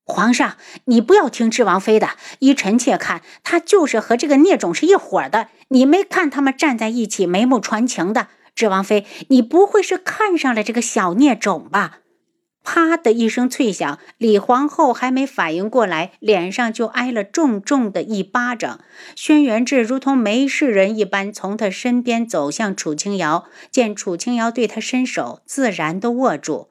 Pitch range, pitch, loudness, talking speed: 210-285 Hz, 245 Hz, -17 LUFS, 255 characters per minute